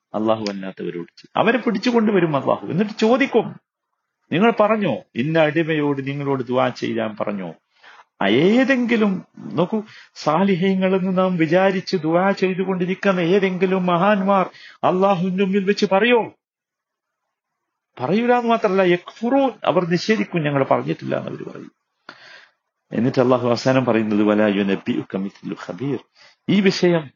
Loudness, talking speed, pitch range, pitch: -19 LUFS, 95 wpm, 140-210 Hz, 185 Hz